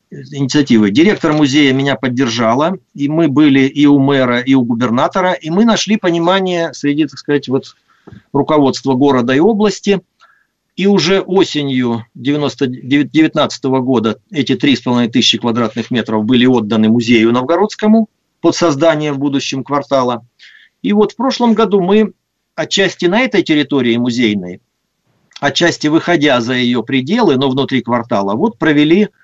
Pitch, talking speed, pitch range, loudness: 145 Hz, 135 wpm, 125-170 Hz, -13 LUFS